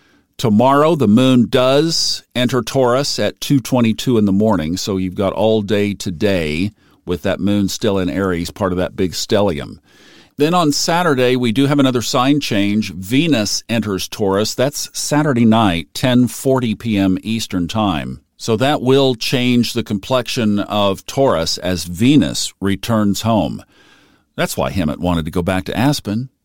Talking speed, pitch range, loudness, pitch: 155 wpm, 95-125 Hz, -16 LUFS, 110 Hz